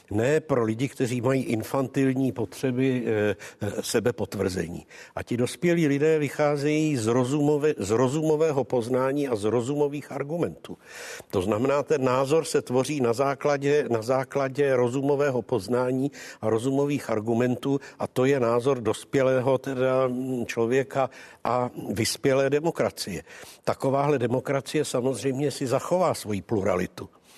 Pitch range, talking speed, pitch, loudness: 125-145 Hz, 115 wpm, 130 Hz, -25 LUFS